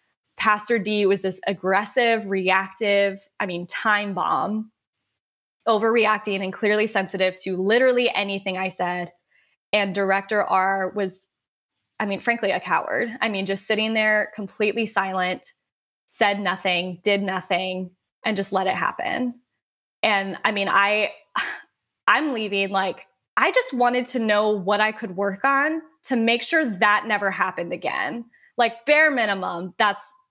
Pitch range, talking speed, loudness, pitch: 190-225 Hz, 145 wpm, -22 LUFS, 205 Hz